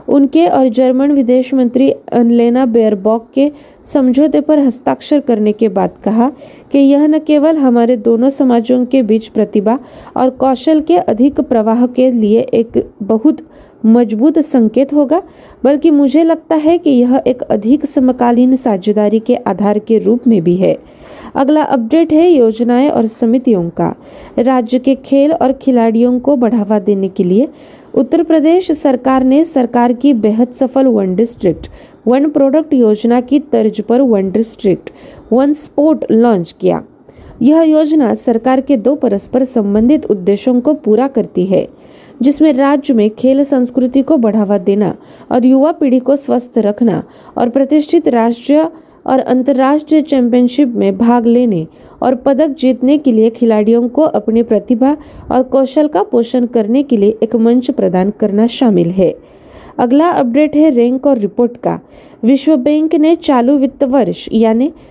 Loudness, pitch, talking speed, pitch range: -11 LUFS, 255 Hz, 150 wpm, 230-285 Hz